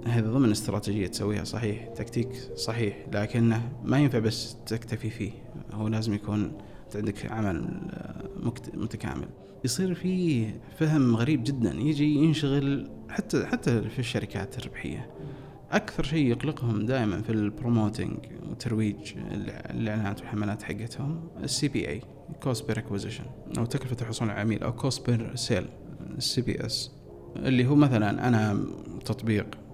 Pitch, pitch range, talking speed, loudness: 115 Hz, 110-135 Hz, 130 wpm, -29 LUFS